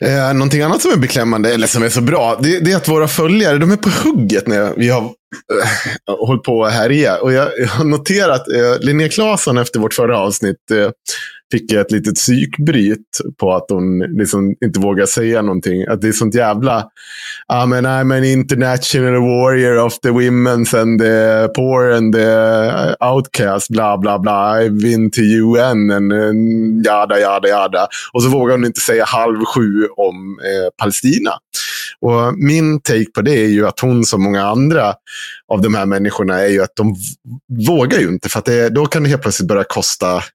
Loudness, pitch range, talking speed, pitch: -13 LUFS, 105-130 Hz, 190 wpm, 115 Hz